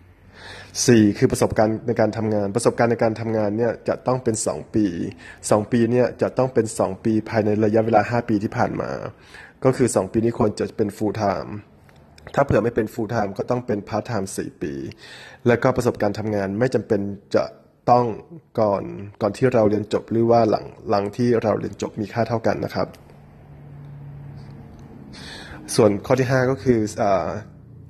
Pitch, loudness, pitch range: 110 Hz, -21 LUFS, 105-120 Hz